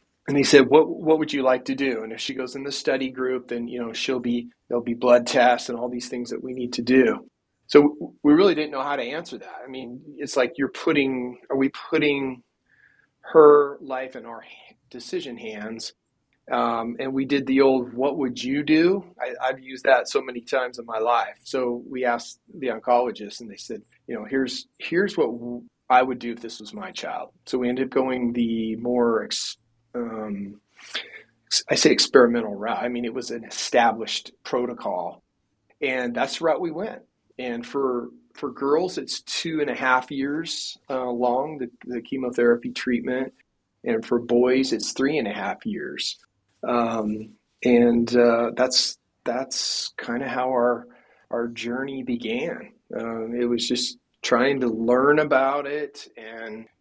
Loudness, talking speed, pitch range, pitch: -23 LUFS, 185 wpm, 120-135 Hz, 125 Hz